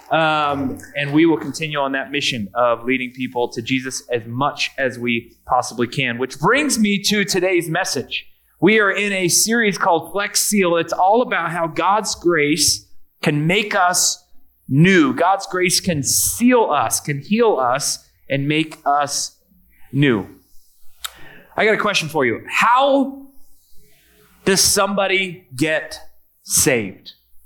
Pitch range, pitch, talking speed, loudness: 135-195 Hz, 160 Hz, 140 wpm, -18 LUFS